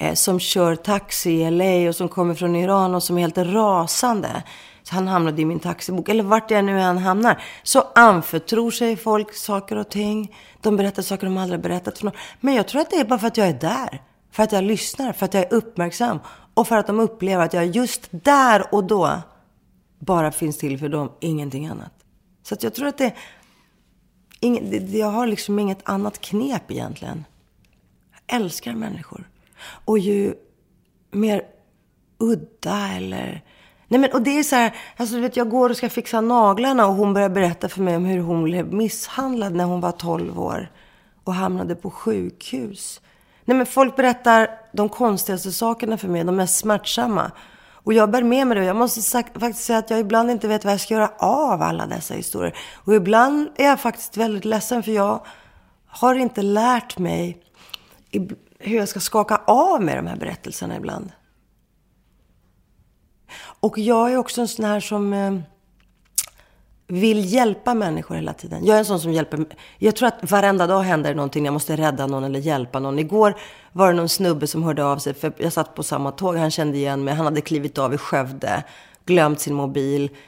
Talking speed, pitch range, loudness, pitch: 195 wpm, 175-225 Hz, -20 LUFS, 205 Hz